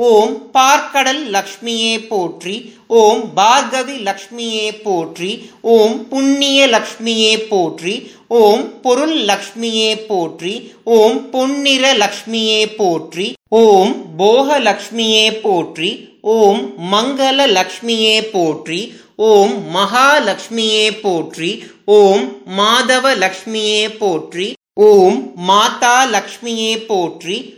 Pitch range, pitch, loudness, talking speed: 205-245 Hz, 220 Hz, -13 LUFS, 85 wpm